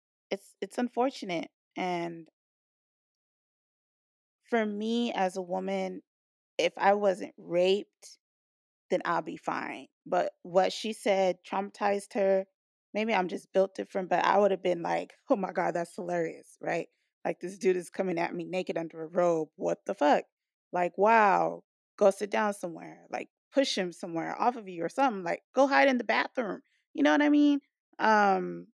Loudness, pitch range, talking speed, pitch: -29 LUFS, 180-220 Hz, 170 wpm, 195 Hz